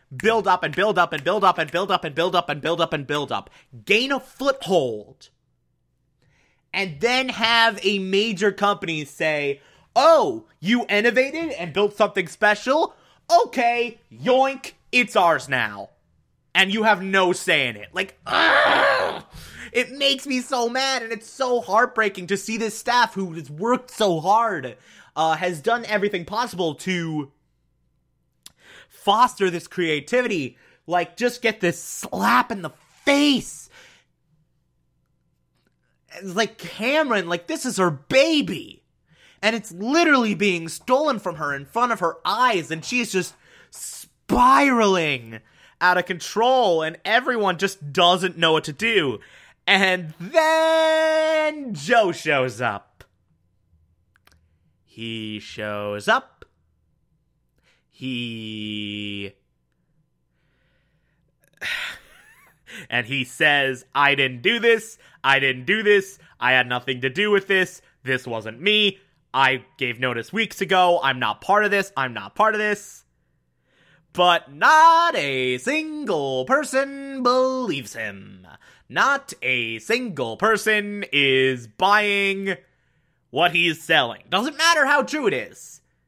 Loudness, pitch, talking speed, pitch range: -21 LUFS, 190 Hz, 135 wpm, 140-235 Hz